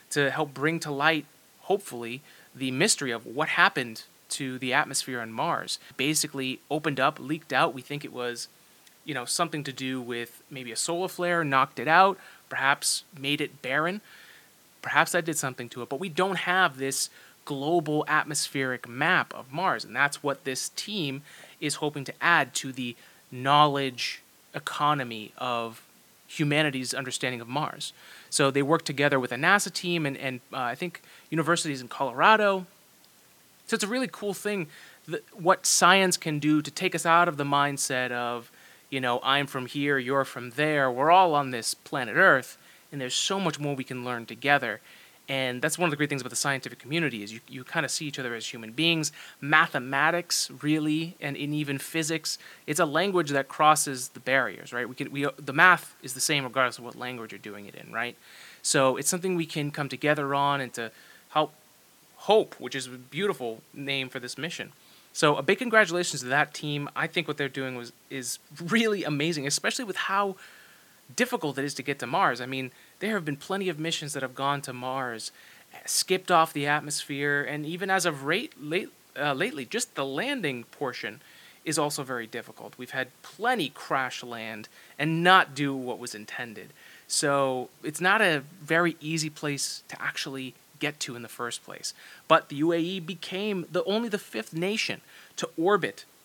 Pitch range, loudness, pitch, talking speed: 130-165 Hz, -27 LUFS, 145 Hz, 190 wpm